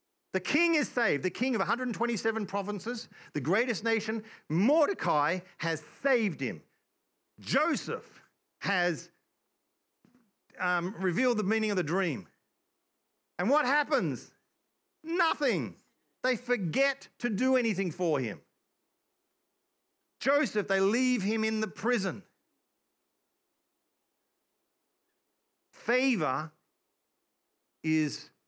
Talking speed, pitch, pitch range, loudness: 95 wpm, 230 Hz, 190-295 Hz, -30 LUFS